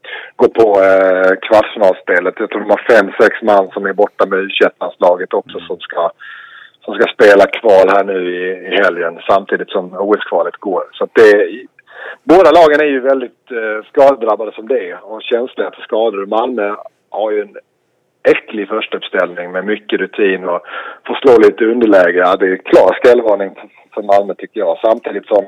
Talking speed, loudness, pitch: 185 wpm, -12 LUFS, 135 Hz